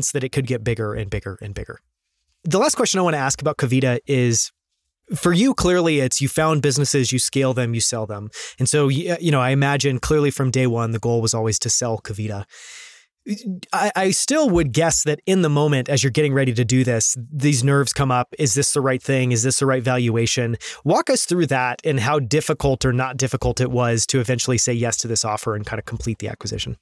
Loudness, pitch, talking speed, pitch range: -19 LUFS, 130 Hz, 230 wpm, 115-150 Hz